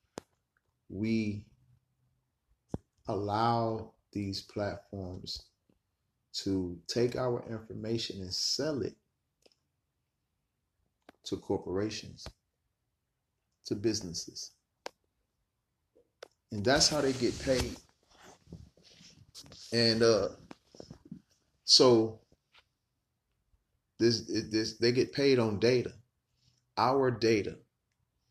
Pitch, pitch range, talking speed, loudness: 115 Hz, 100-120 Hz, 70 wpm, -30 LUFS